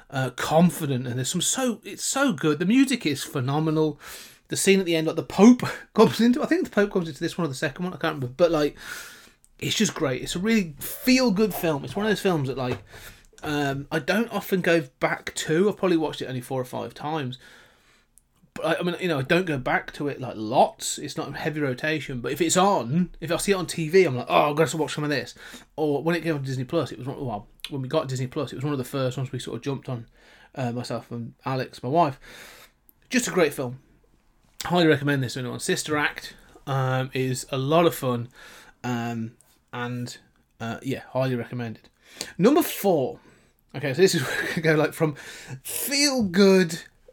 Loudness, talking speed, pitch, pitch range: -24 LUFS, 225 wpm, 155 Hz, 130-175 Hz